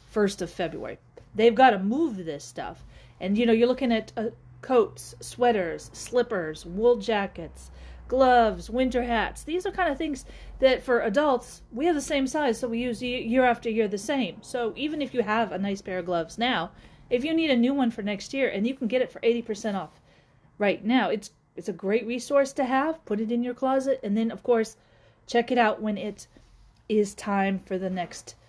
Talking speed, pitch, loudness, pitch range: 215 wpm, 230 Hz, -26 LUFS, 200-255 Hz